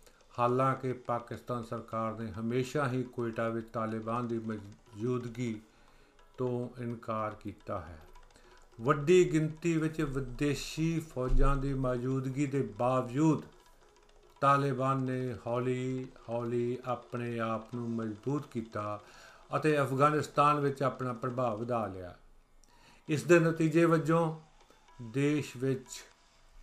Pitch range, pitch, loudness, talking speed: 115-140 Hz, 125 Hz, -32 LUFS, 105 wpm